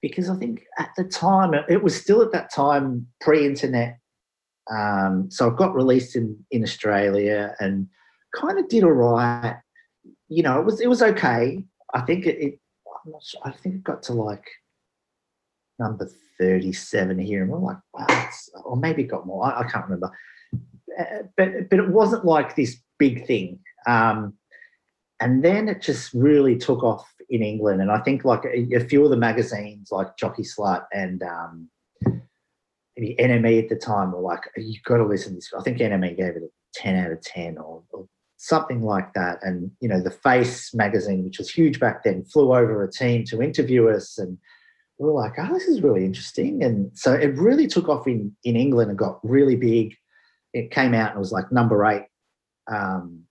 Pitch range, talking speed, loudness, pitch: 105-150 Hz, 195 wpm, -22 LUFS, 120 Hz